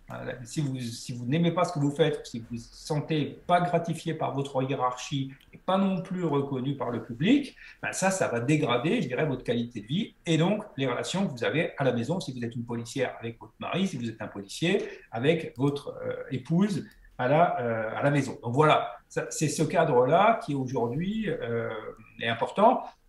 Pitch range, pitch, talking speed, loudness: 120-170 Hz, 145 Hz, 215 wpm, -28 LUFS